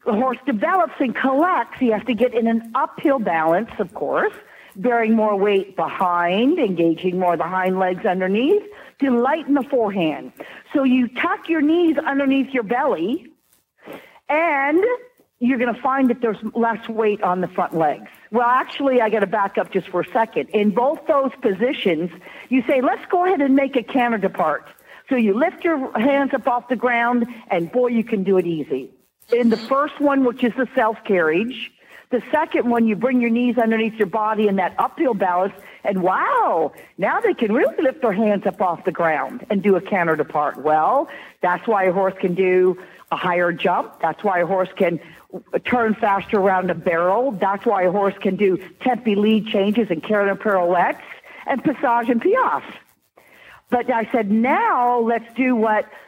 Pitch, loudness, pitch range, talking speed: 230 Hz, -20 LUFS, 190-260 Hz, 190 wpm